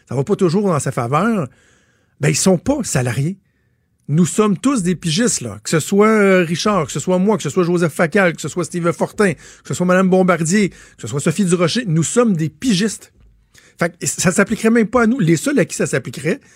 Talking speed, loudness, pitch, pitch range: 245 wpm, -16 LUFS, 180 Hz, 160-210 Hz